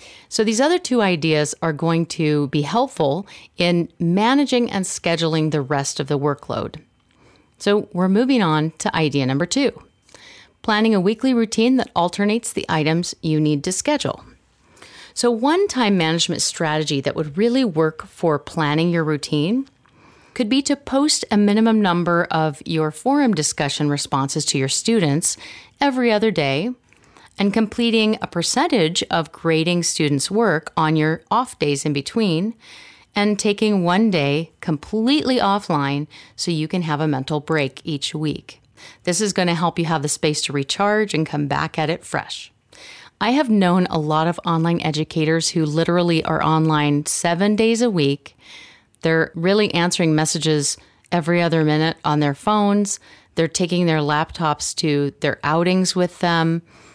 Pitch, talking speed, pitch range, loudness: 170 Hz, 160 wpm, 155-215 Hz, -19 LUFS